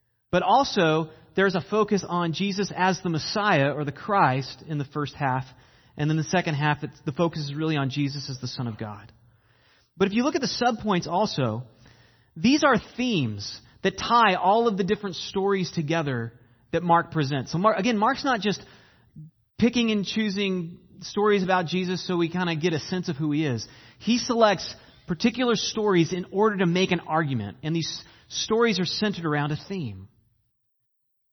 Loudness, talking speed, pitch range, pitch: -25 LUFS, 185 wpm, 135-200 Hz, 165 Hz